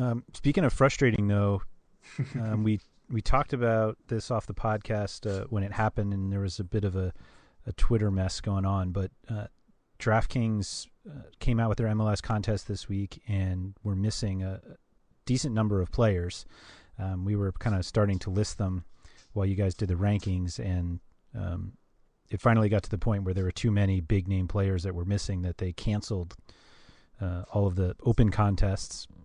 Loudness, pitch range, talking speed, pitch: -29 LUFS, 95-110 Hz, 190 wpm, 100 Hz